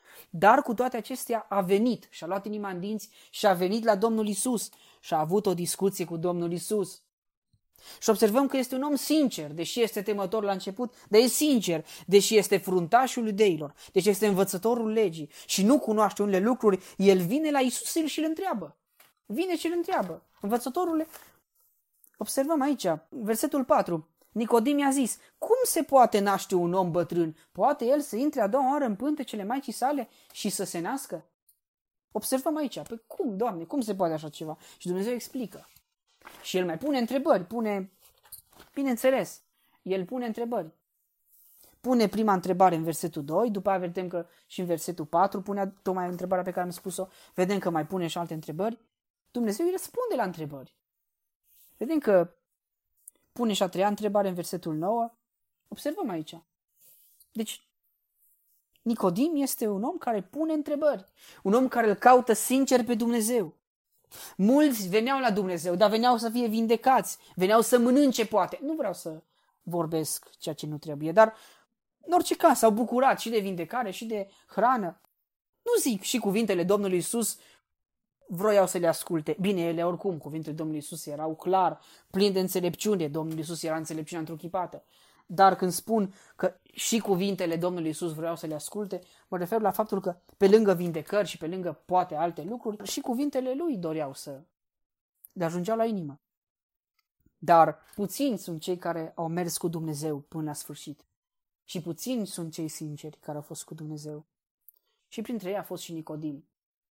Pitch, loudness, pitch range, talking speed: 200 Hz, -27 LUFS, 175-245 Hz, 170 wpm